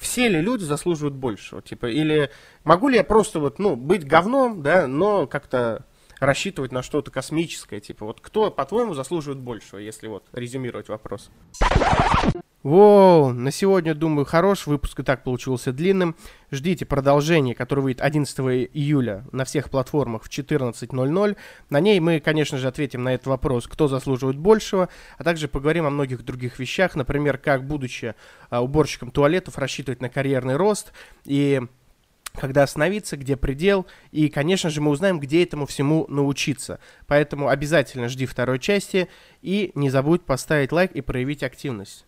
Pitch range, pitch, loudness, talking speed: 130-170 Hz, 145 Hz, -22 LUFS, 155 wpm